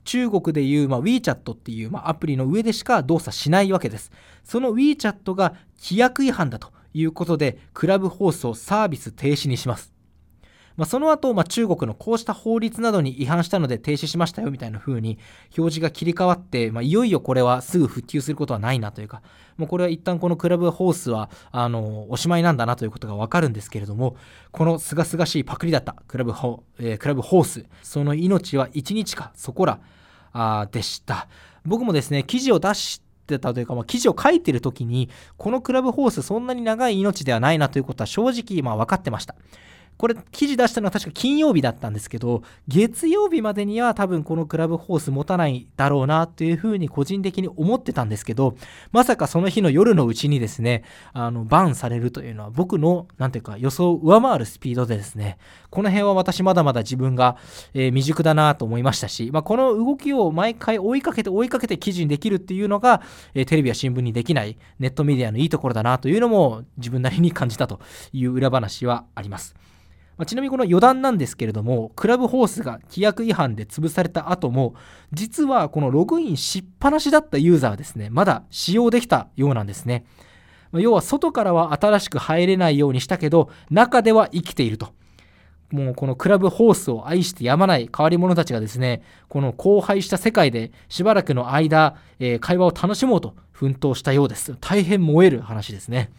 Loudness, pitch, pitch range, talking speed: -21 LUFS, 155 Hz, 125-195 Hz, 415 characters per minute